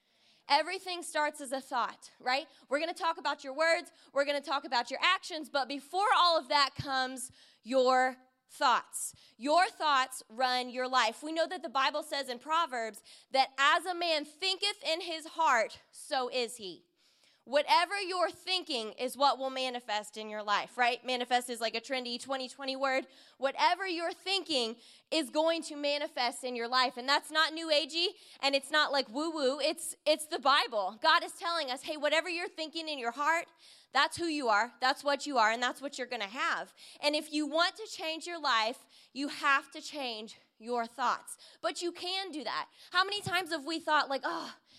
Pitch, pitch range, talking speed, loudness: 285 Hz, 255-325 Hz, 195 wpm, -31 LUFS